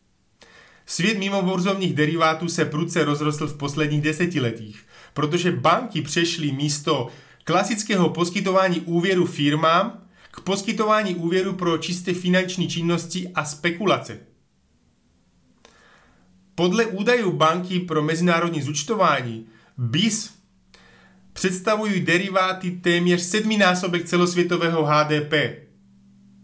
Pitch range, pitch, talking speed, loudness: 150-185 Hz, 170 Hz, 90 wpm, -21 LUFS